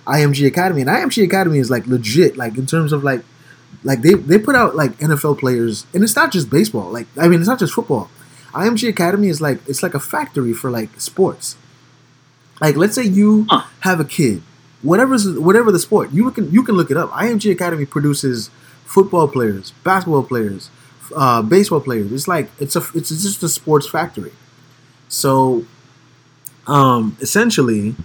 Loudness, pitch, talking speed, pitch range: -15 LUFS, 150 Hz, 180 wpm, 130-185 Hz